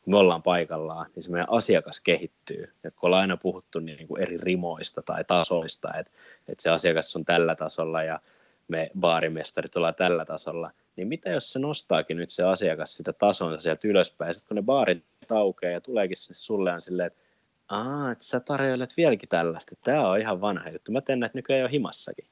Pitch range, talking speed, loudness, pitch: 80-120 Hz, 195 wpm, -27 LUFS, 90 Hz